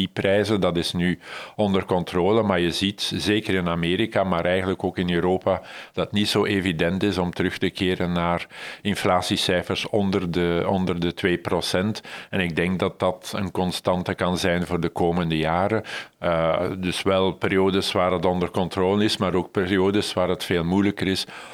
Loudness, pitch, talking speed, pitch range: -23 LUFS, 95 Hz, 180 wpm, 90-100 Hz